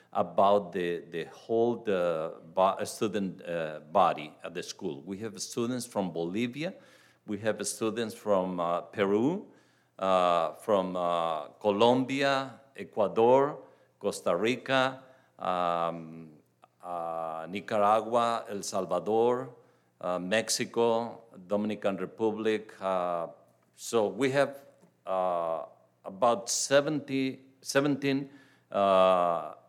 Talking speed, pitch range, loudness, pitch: 95 wpm, 90-125 Hz, -29 LUFS, 105 Hz